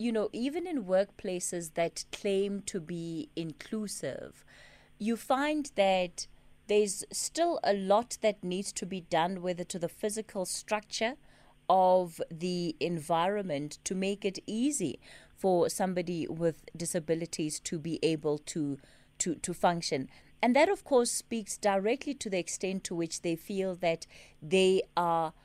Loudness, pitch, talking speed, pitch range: -32 LUFS, 185 Hz, 145 wpm, 170-210 Hz